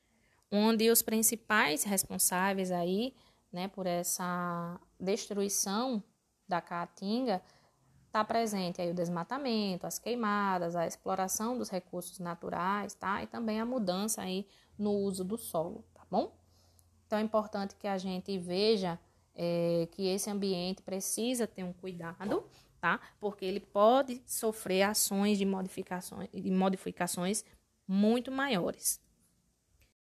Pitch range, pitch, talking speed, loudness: 180-215 Hz, 195 Hz, 125 wpm, -33 LUFS